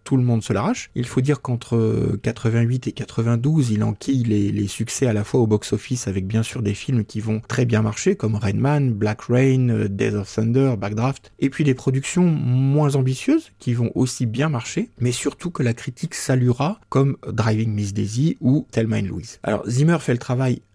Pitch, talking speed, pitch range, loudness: 120 Hz, 200 wpm, 110-135 Hz, -21 LUFS